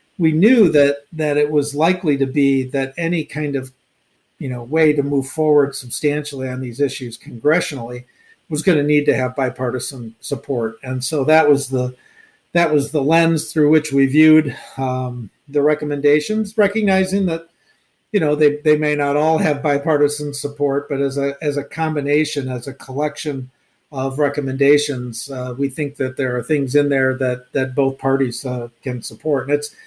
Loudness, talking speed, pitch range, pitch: -18 LUFS, 180 wpm, 130-150 Hz, 145 Hz